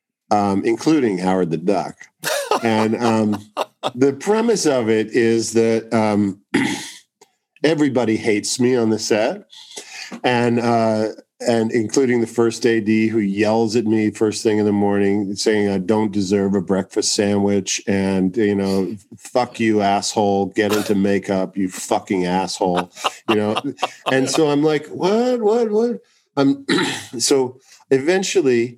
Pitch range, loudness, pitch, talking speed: 100-125 Hz, -19 LUFS, 110 Hz, 140 wpm